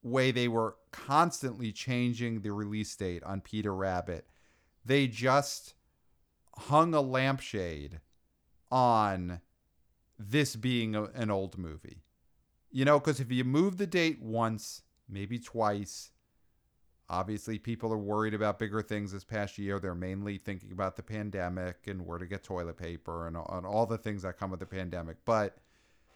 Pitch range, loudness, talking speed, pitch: 90-120 Hz, -33 LUFS, 155 wpm, 105 Hz